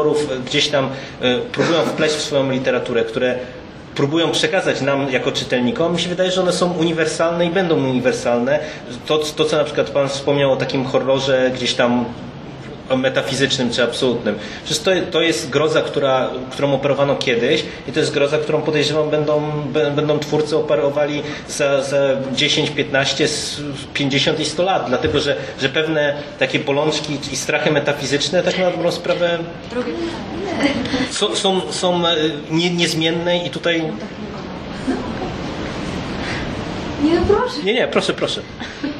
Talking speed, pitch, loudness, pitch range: 130 wpm, 150 Hz, -18 LUFS, 135-165 Hz